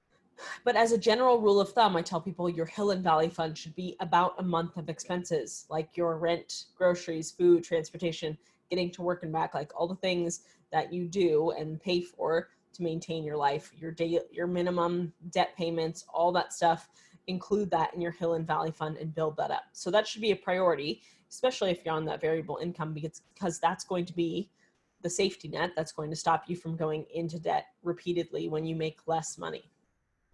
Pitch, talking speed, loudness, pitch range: 170 Hz, 210 wpm, -31 LUFS, 165-180 Hz